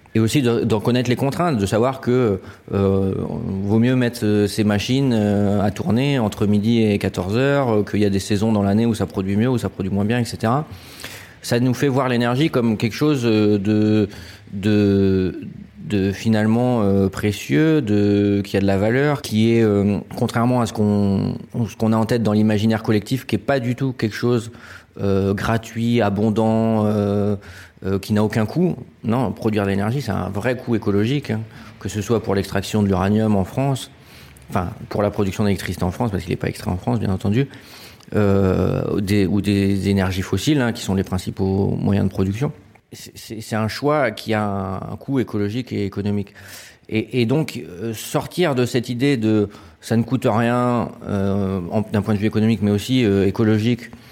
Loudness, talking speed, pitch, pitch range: -20 LUFS, 200 wpm, 110 Hz, 100-120 Hz